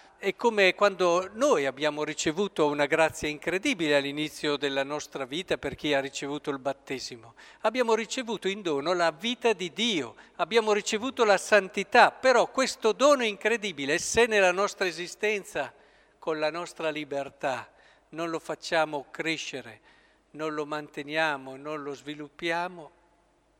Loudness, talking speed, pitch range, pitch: -27 LUFS, 135 wpm, 150-205 Hz, 165 Hz